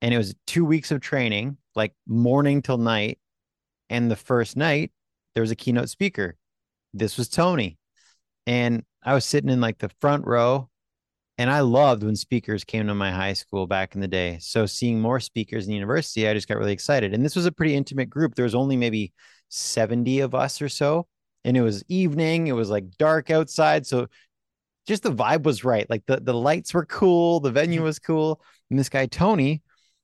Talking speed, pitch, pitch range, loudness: 205 wpm, 125 Hz, 110-150 Hz, -23 LUFS